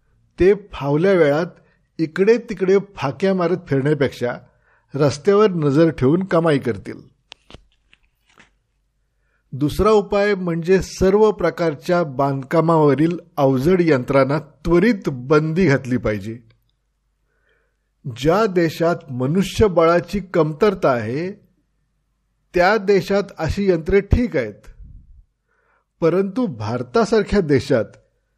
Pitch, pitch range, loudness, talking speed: 165 Hz, 140-195 Hz, -18 LUFS, 80 wpm